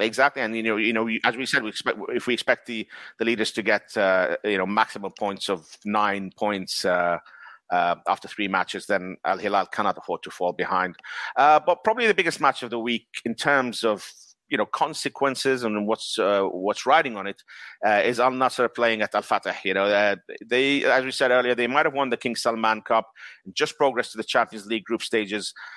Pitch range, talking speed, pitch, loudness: 105-130 Hz, 220 wpm, 115 Hz, -24 LUFS